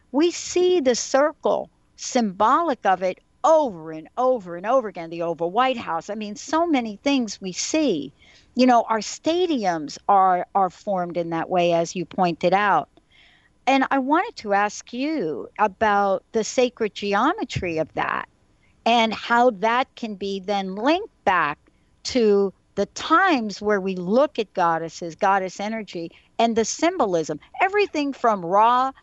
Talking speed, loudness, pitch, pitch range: 155 wpm, -22 LUFS, 220 Hz, 190-265 Hz